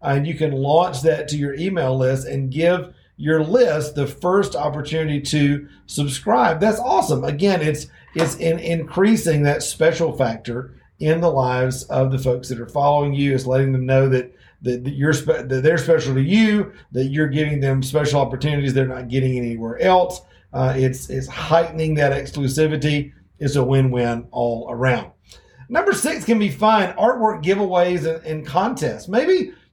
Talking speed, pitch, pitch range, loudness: 170 wpm, 145 Hz, 130-165 Hz, -19 LUFS